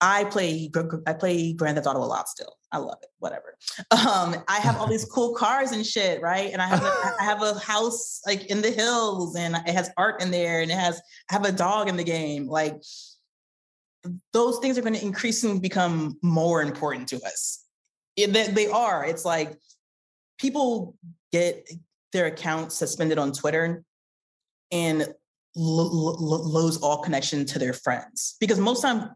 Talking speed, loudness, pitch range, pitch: 180 wpm, -25 LUFS, 160-210 Hz, 175 Hz